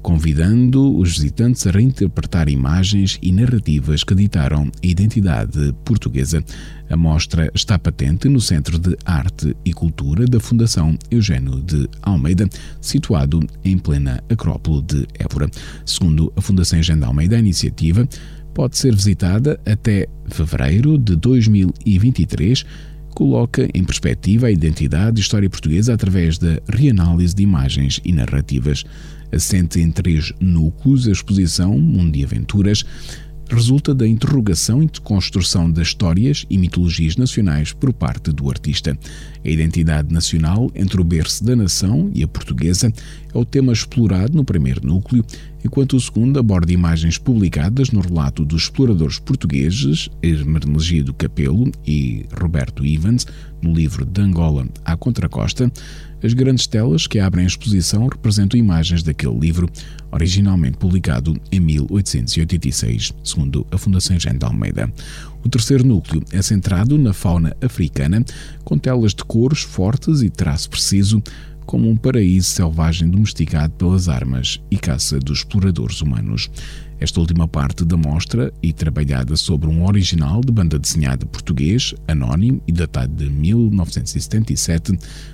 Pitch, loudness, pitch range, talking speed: 90 Hz, -17 LUFS, 80-115 Hz, 140 wpm